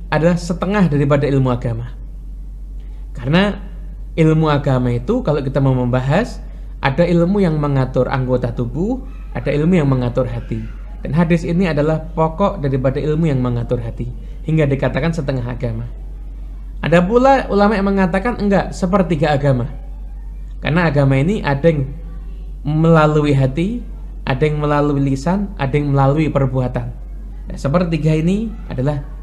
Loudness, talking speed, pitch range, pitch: -17 LUFS, 135 wpm, 135-175 Hz, 150 Hz